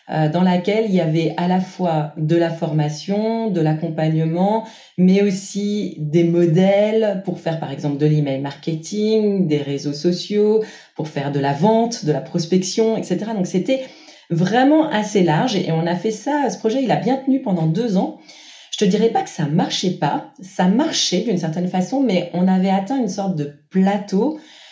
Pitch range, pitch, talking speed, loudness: 165-220 Hz, 185 Hz, 185 wpm, -19 LUFS